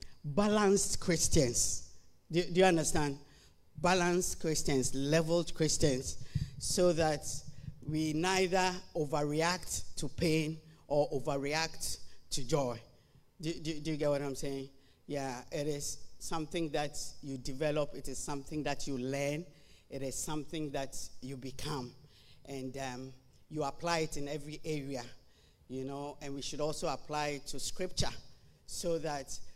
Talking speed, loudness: 140 wpm, -35 LUFS